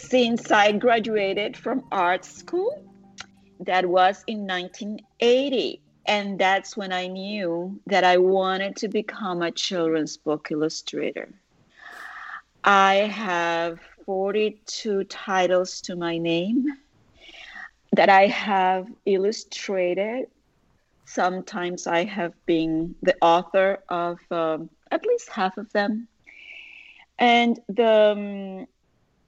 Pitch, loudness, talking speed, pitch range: 195 Hz, -23 LUFS, 105 wpm, 180-220 Hz